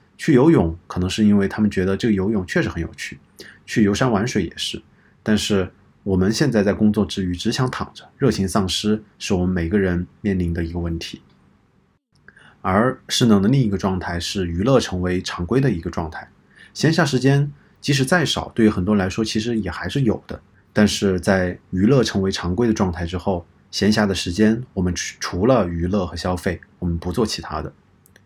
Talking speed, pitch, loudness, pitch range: 295 characters per minute, 95 Hz, -20 LUFS, 90-110 Hz